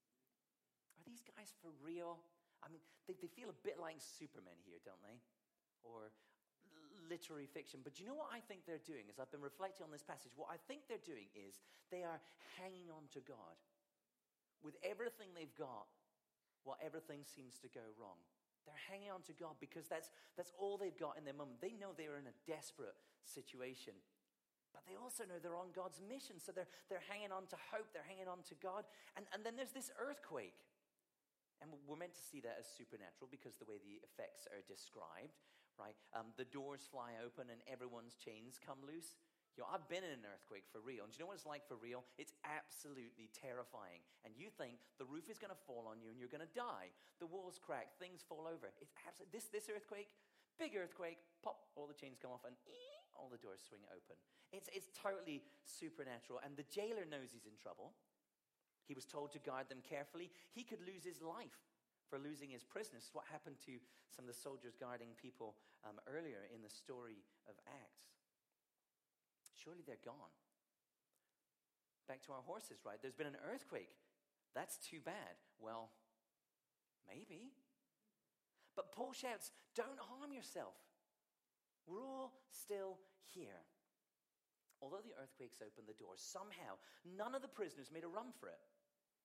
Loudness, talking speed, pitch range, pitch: -54 LUFS, 185 wpm, 130-200 Hz, 165 Hz